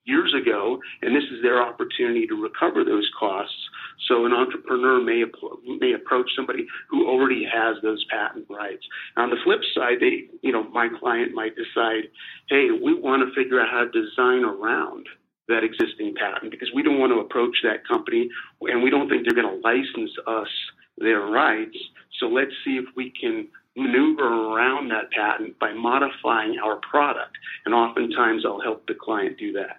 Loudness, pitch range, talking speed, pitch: -23 LUFS, 325-370 Hz, 180 wpm, 350 Hz